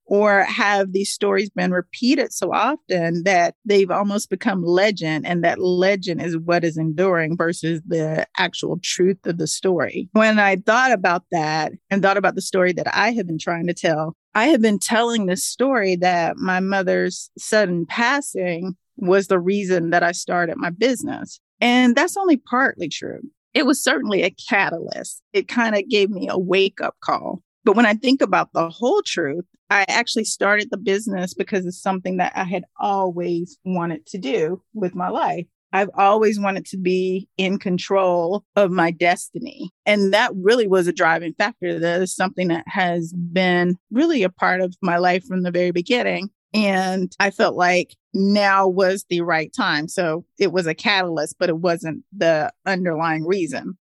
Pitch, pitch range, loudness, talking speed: 185 Hz, 175-205 Hz, -20 LUFS, 180 wpm